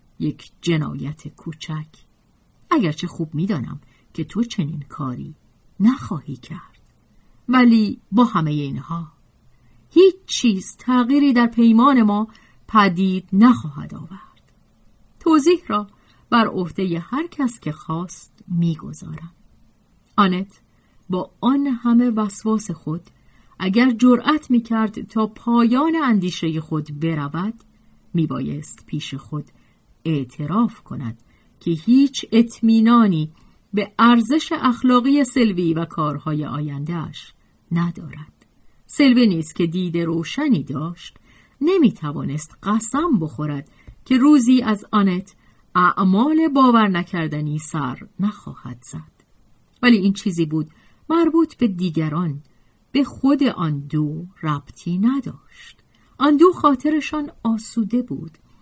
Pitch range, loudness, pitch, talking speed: 155-240 Hz, -19 LUFS, 195 Hz, 105 wpm